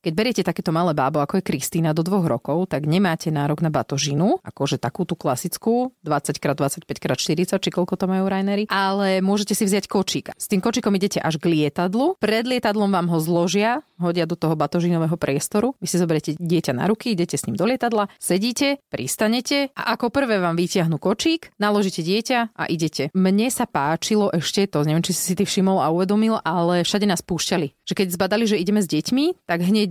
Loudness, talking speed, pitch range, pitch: -21 LUFS, 195 wpm, 165-210 Hz, 185 Hz